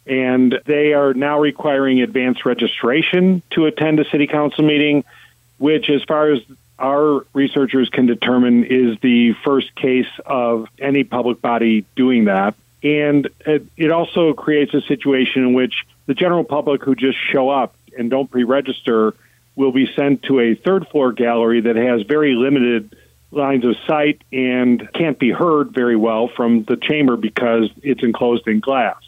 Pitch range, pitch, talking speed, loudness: 120-145 Hz, 130 Hz, 160 wpm, -16 LUFS